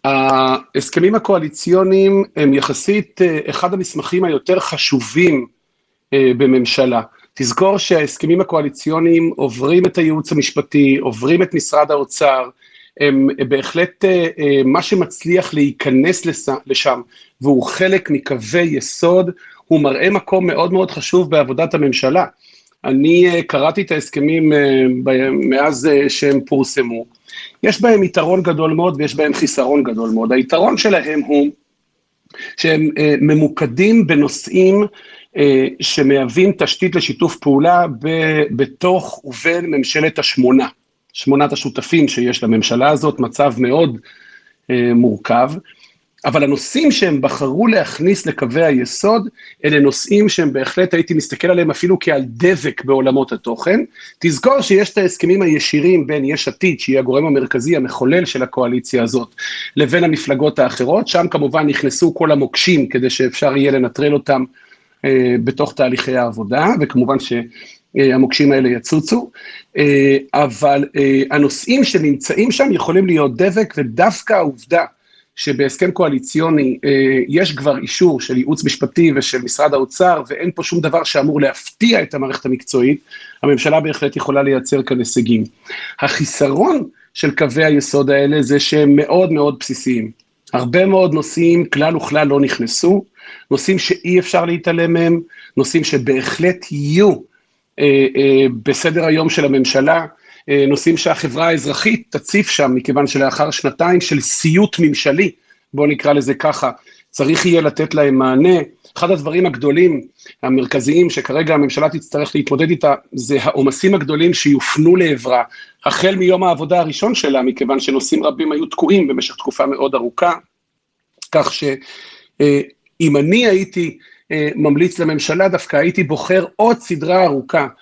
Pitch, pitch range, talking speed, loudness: 150 Hz, 135-175 Hz, 125 wpm, -14 LUFS